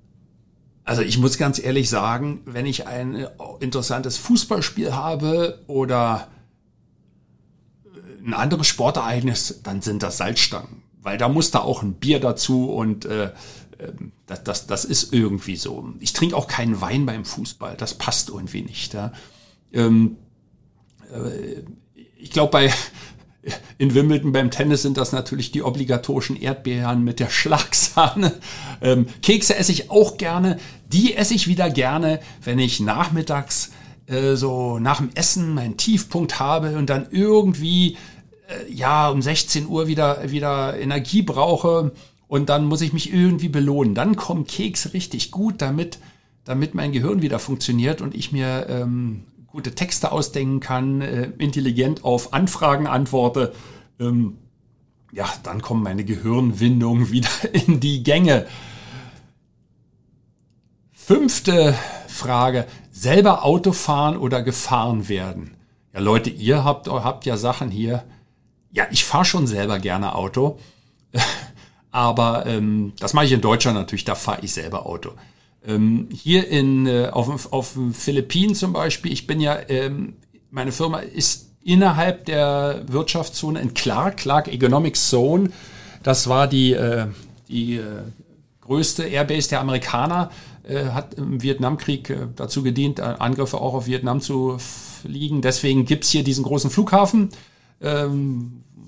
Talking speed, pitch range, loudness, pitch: 135 wpm, 120-155 Hz, -20 LUFS, 135 Hz